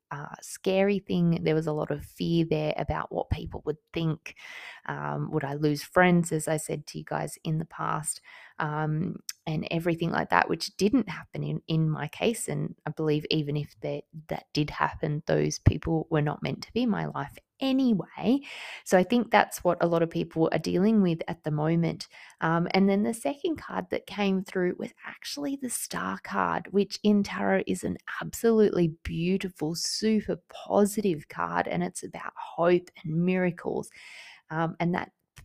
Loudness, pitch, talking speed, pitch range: -28 LUFS, 170 Hz, 185 wpm, 155-200 Hz